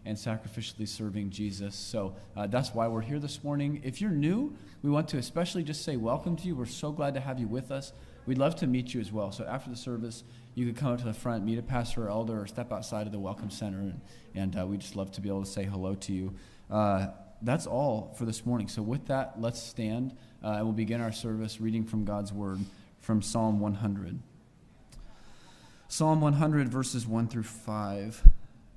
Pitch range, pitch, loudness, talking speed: 105-130 Hz, 115 Hz, -32 LUFS, 220 wpm